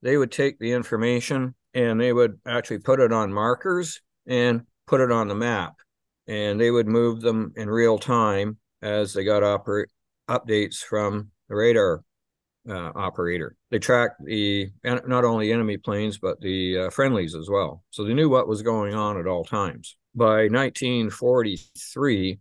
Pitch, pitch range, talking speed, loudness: 115 Hz, 105-125 Hz, 165 wpm, -23 LUFS